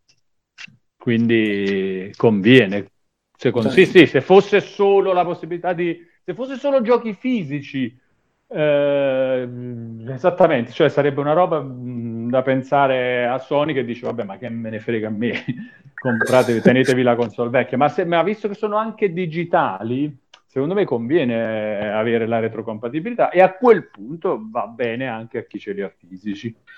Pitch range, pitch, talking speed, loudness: 115-180 Hz, 130 Hz, 150 wpm, -19 LUFS